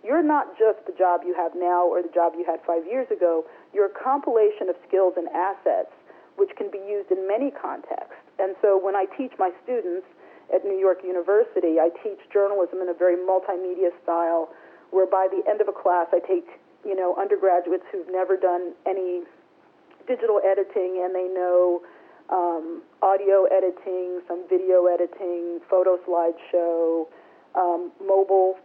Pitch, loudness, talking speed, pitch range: 185 Hz, -23 LUFS, 170 wpm, 175-200 Hz